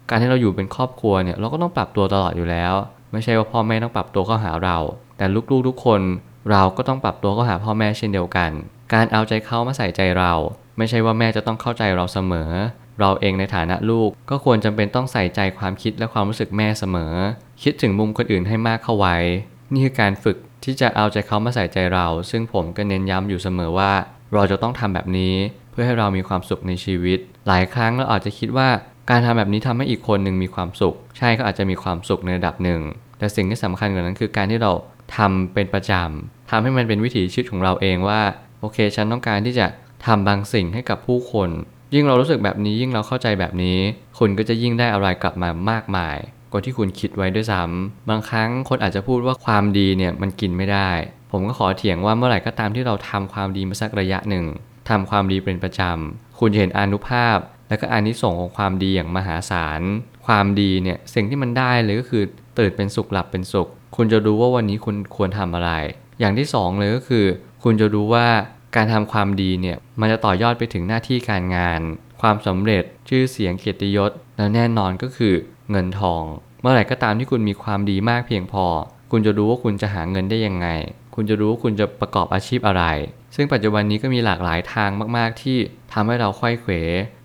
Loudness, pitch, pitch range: -20 LUFS, 105 Hz, 95-115 Hz